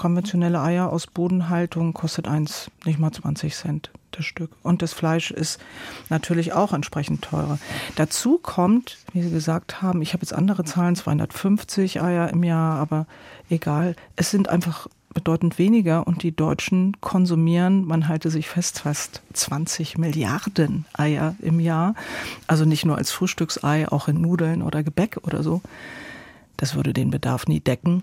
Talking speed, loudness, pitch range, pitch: 160 wpm, -23 LUFS, 155-180 Hz, 165 Hz